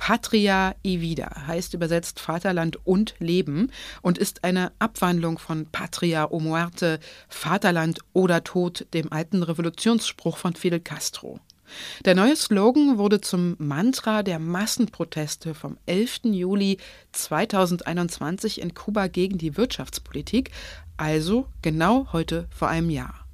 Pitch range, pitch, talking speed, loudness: 165-205 Hz, 180 Hz, 125 wpm, -24 LUFS